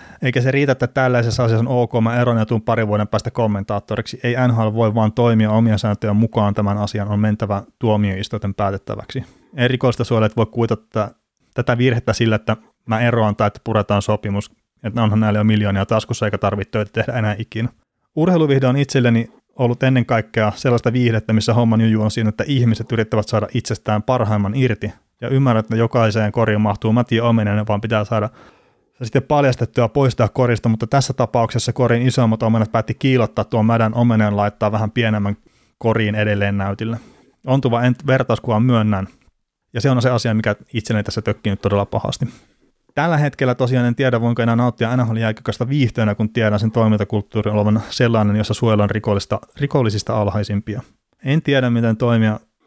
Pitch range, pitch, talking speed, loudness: 105-120 Hz, 115 Hz, 170 wpm, -18 LUFS